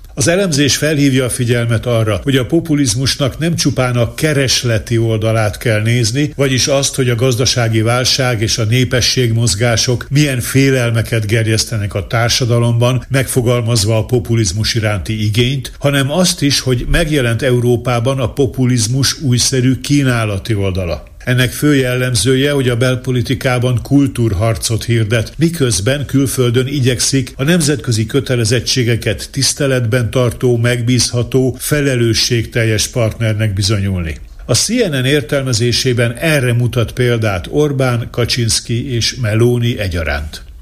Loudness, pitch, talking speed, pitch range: -14 LUFS, 125 Hz, 115 wpm, 115-135 Hz